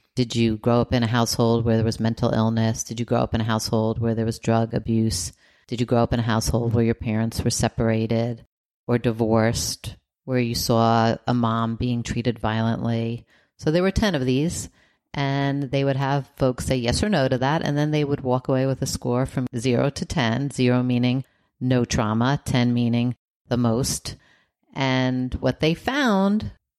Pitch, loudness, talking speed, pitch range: 120 Hz, -23 LUFS, 195 wpm, 115-130 Hz